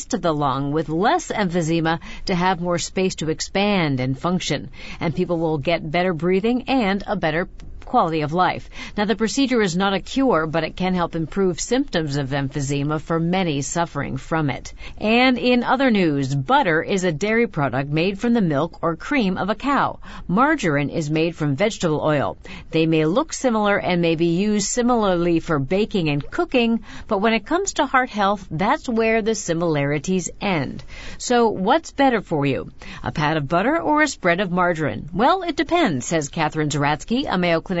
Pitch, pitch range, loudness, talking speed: 180 Hz, 160-225 Hz, -21 LUFS, 185 wpm